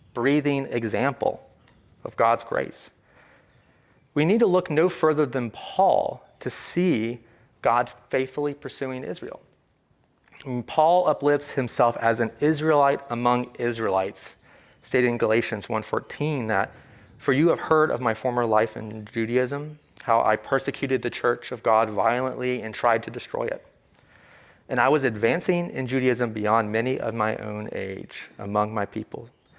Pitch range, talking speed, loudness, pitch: 115-145 Hz, 145 wpm, -24 LUFS, 125 Hz